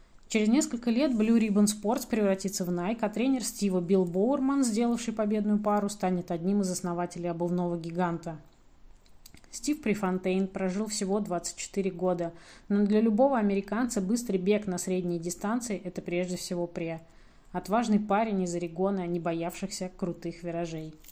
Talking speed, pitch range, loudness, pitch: 140 wpm, 175-215 Hz, -29 LUFS, 195 Hz